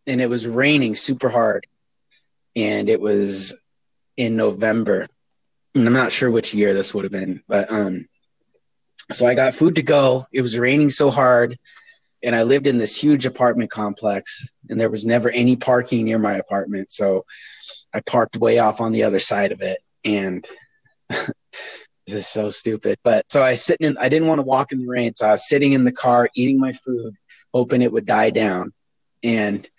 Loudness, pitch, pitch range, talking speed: -19 LUFS, 120 Hz, 105-130 Hz, 195 wpm